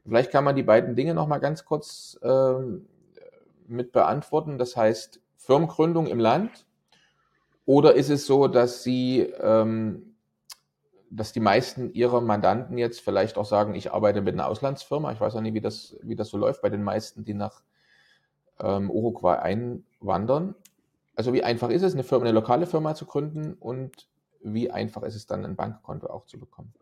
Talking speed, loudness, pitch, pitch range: 180 wpm, -25 LUFS, 125 Hz, 110-145 Hz